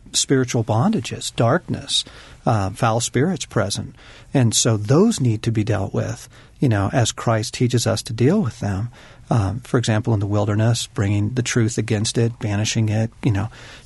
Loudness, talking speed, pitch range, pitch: -20 LUFS, 175 wpm, 110-125 Hz, 115 Hz